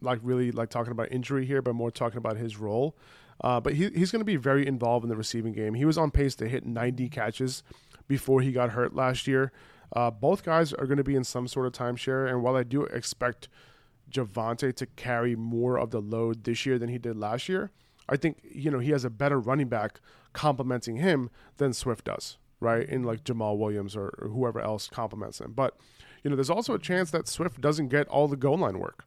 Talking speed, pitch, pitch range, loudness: 235 wpm, 125 Hz, 115-140 Hz, -29 LUFS